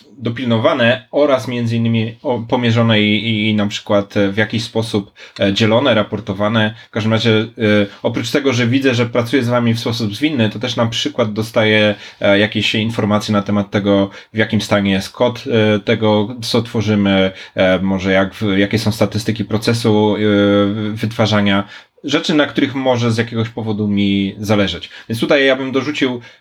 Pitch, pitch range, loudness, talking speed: 110 Hz, 105-120 Hz, -15 LUFS, 150 wpm